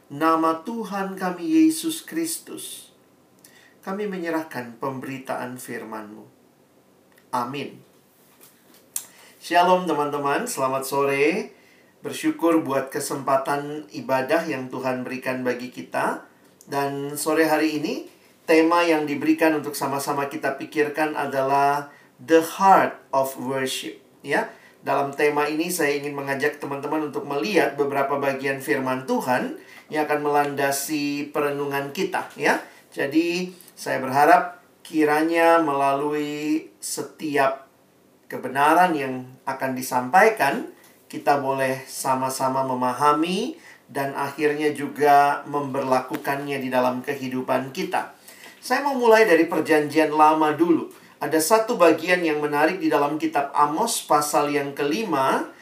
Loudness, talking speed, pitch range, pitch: -22 LUFS, 110 wpm, 135-160 Hz, 145 Hz